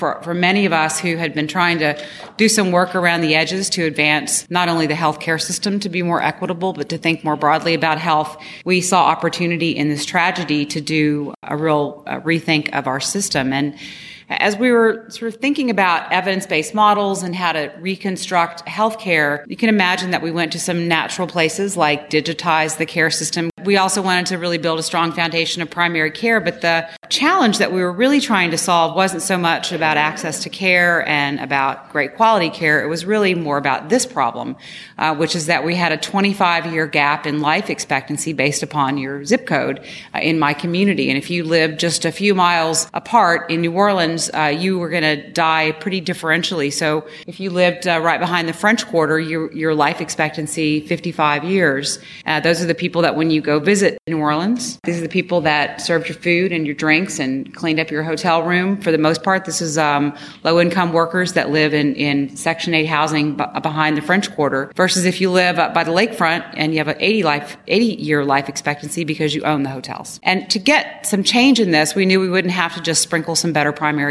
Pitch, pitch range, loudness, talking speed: 165 Hz, 155-180 Hz, -17 LUFS, 220 wpm